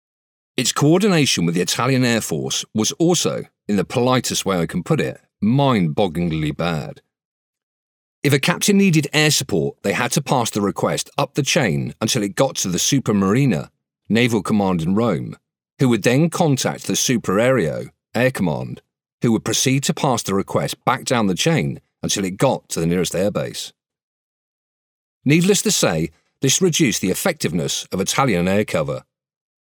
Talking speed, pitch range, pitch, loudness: 170 wpm, 105-160 Hz, 135 Hz, -19 LUFS